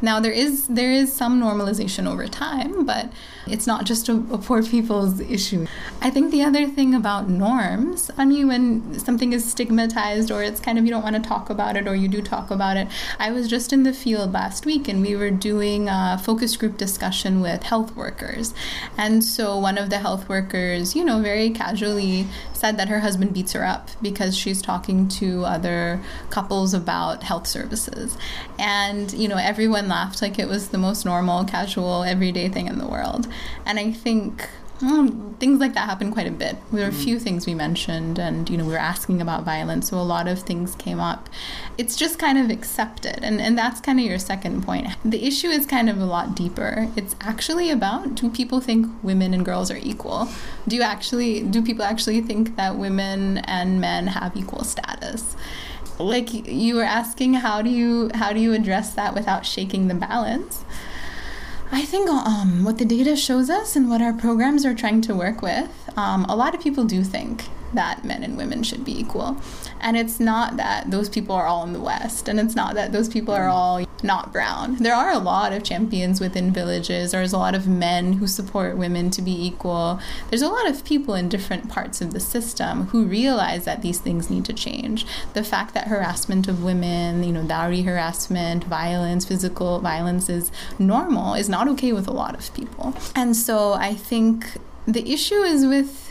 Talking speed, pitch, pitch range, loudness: 205 wpm, 215 Hz, 190-240 Hz, -22 LUFS